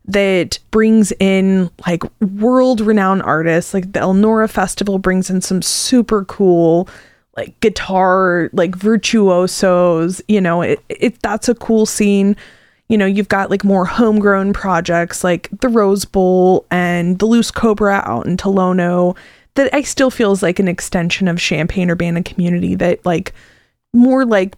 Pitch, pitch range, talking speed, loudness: 195 Hz, 180-215 Hz, 150 wpm, -14 LUFS